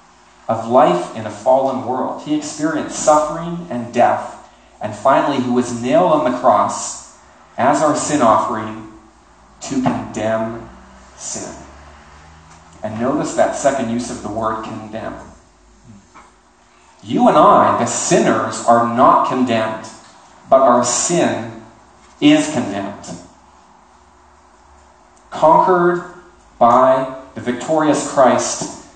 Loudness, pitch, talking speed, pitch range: -16 LUFS, 115 Hz, 110 wpm, 110-135 Hz